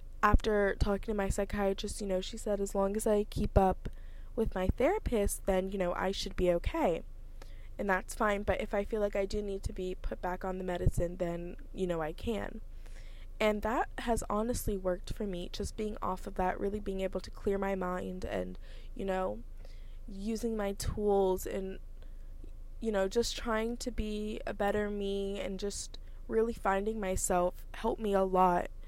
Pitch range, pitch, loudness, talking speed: 180-210 Hz, 195 Hz, -34 LUFS, 190 wpm